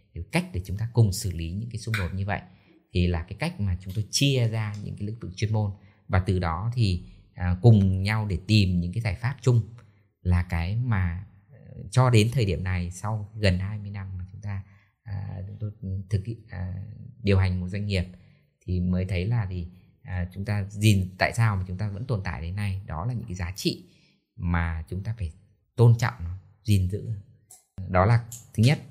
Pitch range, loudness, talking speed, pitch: 90-110 Hz, -27 LUFS, 210 wpm, 100 Hz